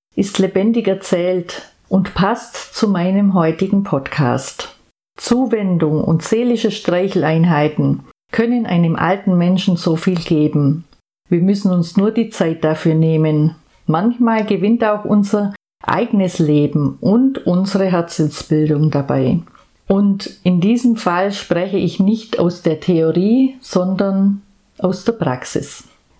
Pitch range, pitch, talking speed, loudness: 165-205 Hz, 185 Hz, 120 wpm, -16 LUFS